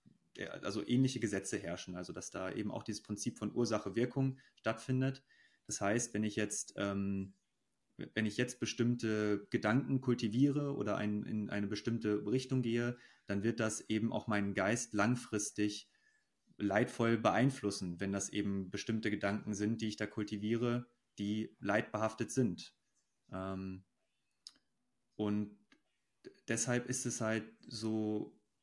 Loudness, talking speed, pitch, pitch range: -37 LUFS, 135 wpm, 110 Hz, 105-120 Hz